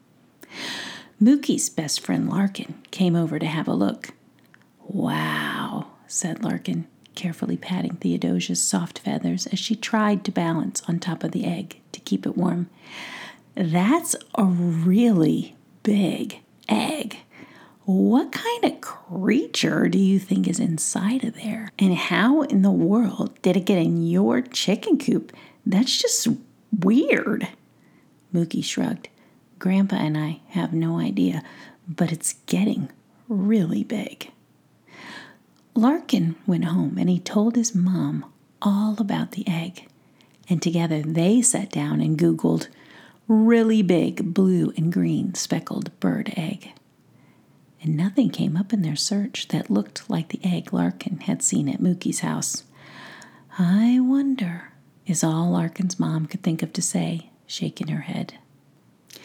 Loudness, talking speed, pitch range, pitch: -23 LUFS, 135 wpm, 170-225 Hz, 190 Hz